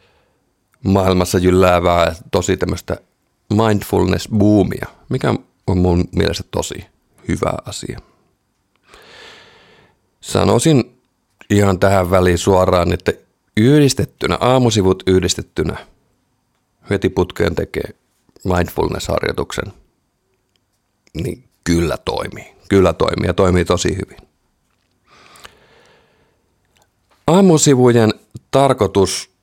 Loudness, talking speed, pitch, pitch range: -16 LUFS, 75 wpm, 95 Hz, 90-110 Hz